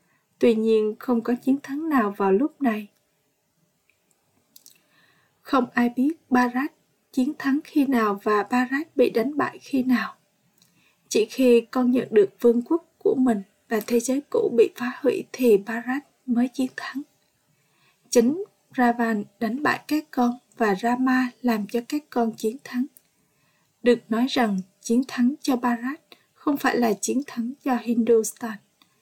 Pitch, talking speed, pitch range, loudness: 245 Hz, 155 wpm, 230-270 Hz, -23 LUFS